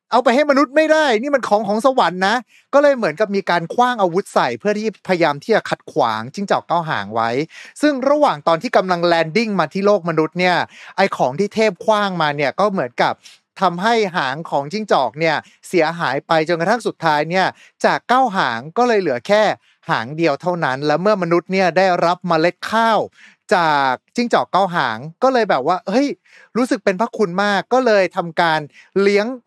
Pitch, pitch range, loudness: 195 Hz, 170-225 Hz, -17 LUFS